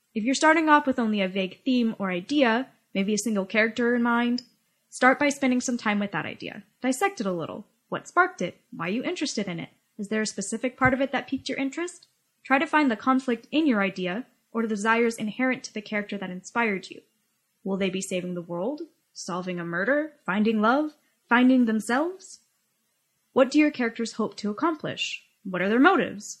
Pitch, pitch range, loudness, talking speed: 235 Hz, 205-265 Hz, -25 LUFS, 205 wpm